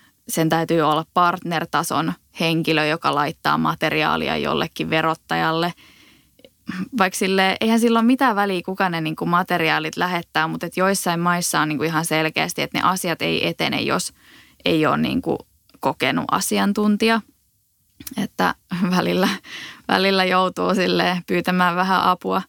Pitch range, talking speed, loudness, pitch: 160-190 Hz, 120 wpm, -20 LUFS, 175 Hz